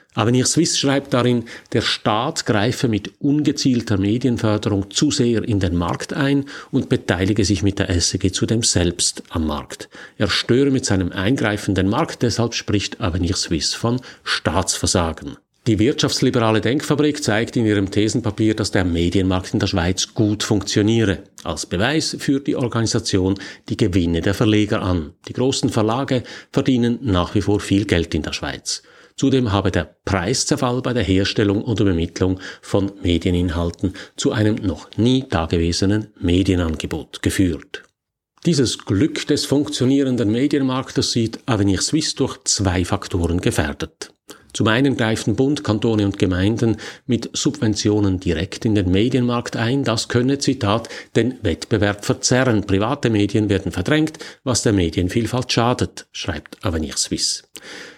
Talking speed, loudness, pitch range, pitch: 140 wpm, -19 LUFS, 95-125 Hz, 110 Hz